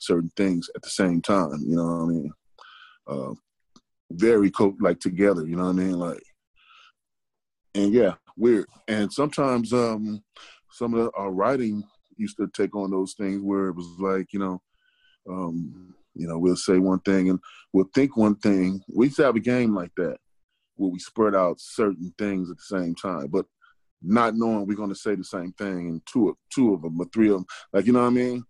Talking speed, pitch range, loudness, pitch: 215 wpm, 90-105 Hz, -24 LUFS, 95 Hz